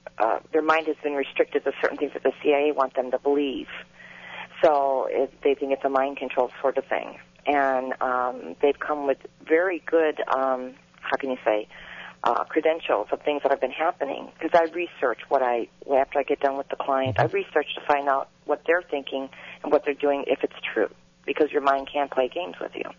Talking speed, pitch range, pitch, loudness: 215 wpm, 130-150 Hz, 140 Hz, -25 LUFS